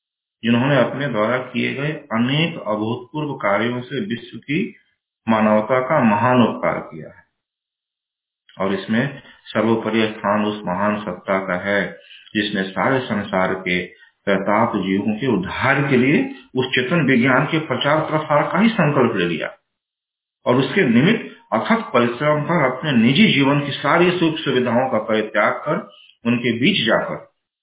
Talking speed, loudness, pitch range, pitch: 145 wpm, -19 LUFS, 105-150 Hz, 125 Hz